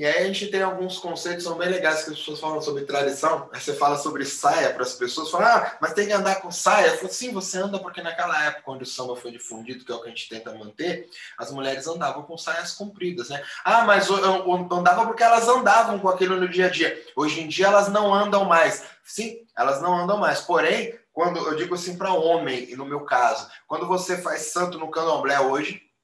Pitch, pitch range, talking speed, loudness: 175 Hz, 150-195 Hz, 235 wpm, -23 LUFS